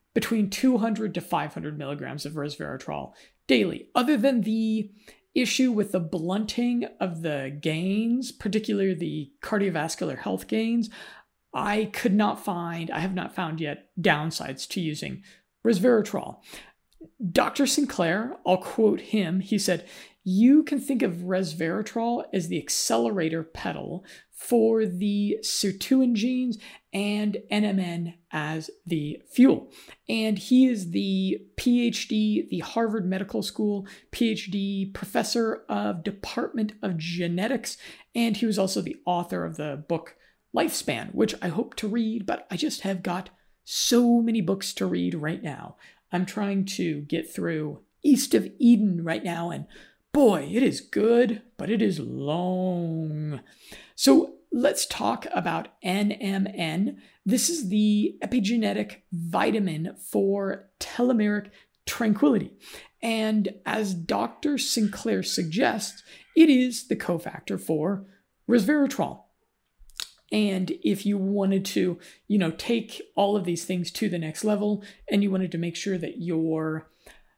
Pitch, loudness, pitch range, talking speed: 200 Hz, -26 LUFS, 175-225 Hz, 130 wpm